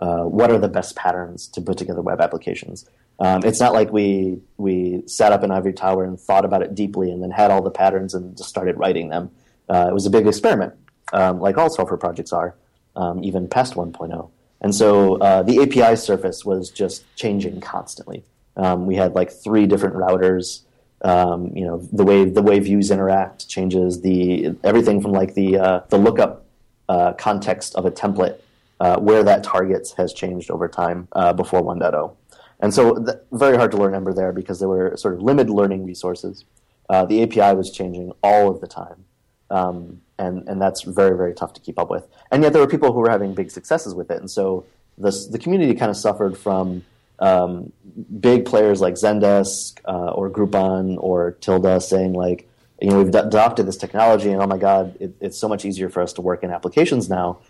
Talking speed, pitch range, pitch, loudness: 205 wpm, 90-105 Hz, 95 Hz, -18 LUFS